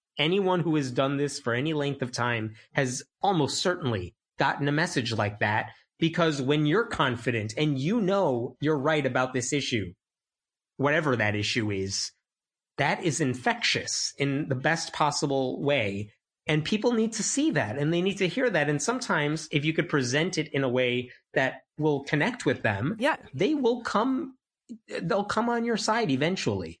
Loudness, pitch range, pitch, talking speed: -27 LUFS, 125-175 Hz, 145 Hz, 175 wpm